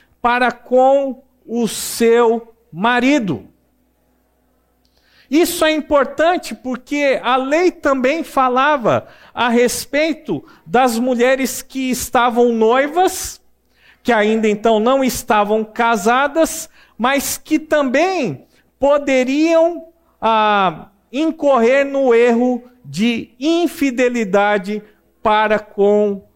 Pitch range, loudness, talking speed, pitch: 230-285 Hz, -16 LUFS, 85 wpm, 255 Hz